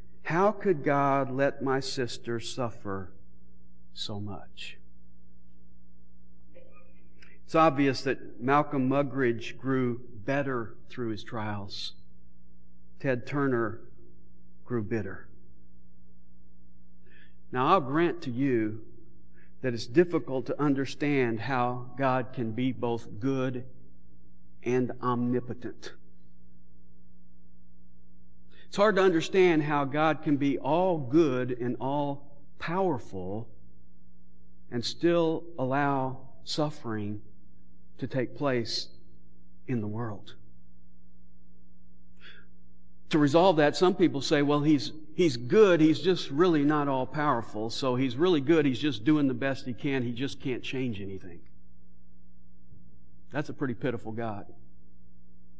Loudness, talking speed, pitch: -28 LUFS, 110 wpm, 115 Hz